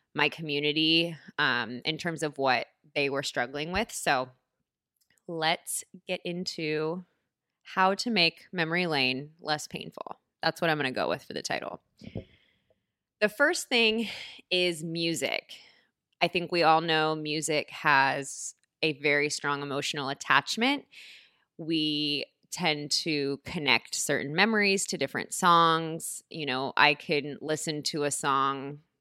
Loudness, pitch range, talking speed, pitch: -28 LUFS, 145-175 Hz, 135 wpm, 155 Hz